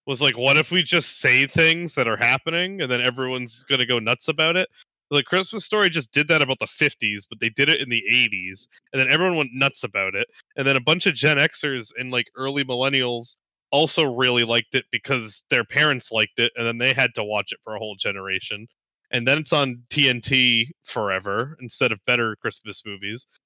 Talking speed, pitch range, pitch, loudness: 215 wpm, 120-150 Hz, 130 Hz, -20 LUFS